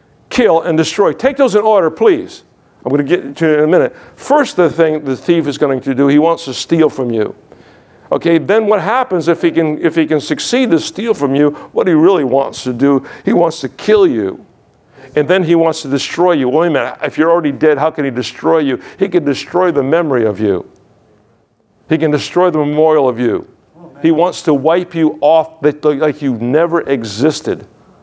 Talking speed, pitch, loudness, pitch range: 215 wpm, 160 Hz, -13 LUFS, 140-180 Hz